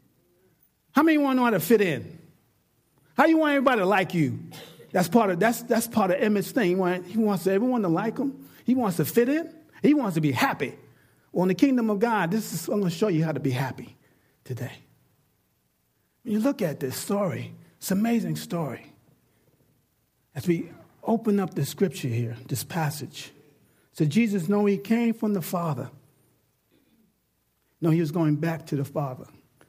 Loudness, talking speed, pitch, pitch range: -25 LUFS, 185 wpm, 175 Hz, 145-220 Hz